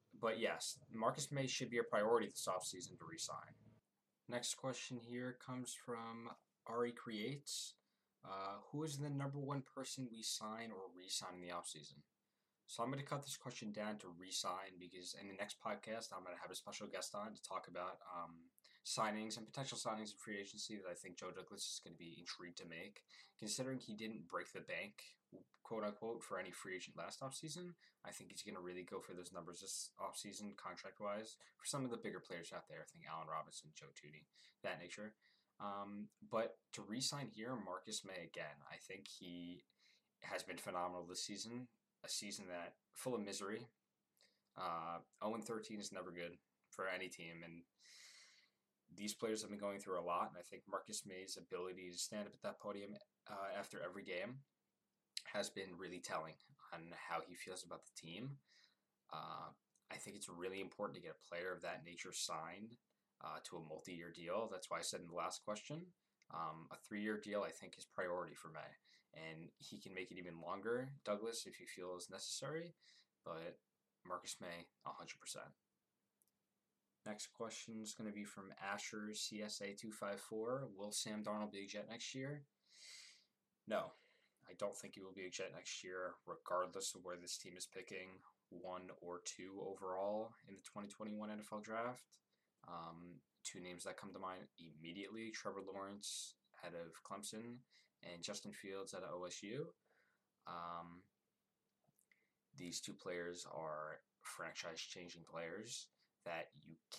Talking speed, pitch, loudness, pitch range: 180 wpm, 100 Hz, -48 LUFS, 90-115 Hz